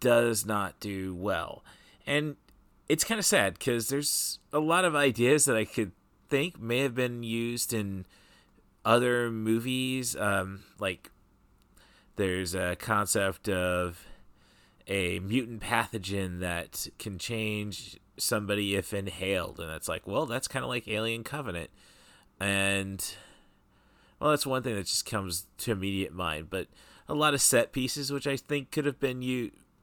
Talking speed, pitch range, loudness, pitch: 150 wpm, 95-130 Hz, -30 LUFS, 110 Hz